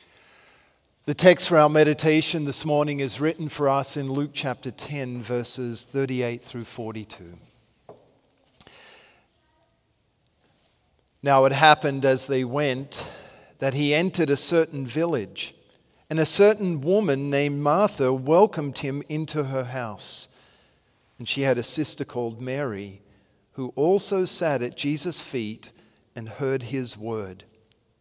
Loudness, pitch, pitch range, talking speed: -23 LUFS, 135 Hz, 120-150 Hz, 125 wpm